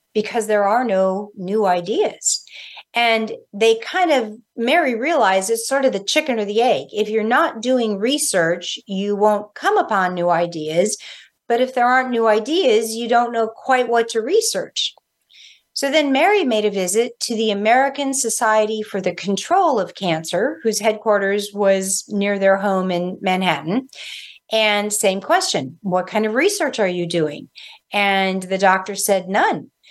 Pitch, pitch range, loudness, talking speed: 215 Hz, 195-245 Hz, -18 LUFS, 165 wpm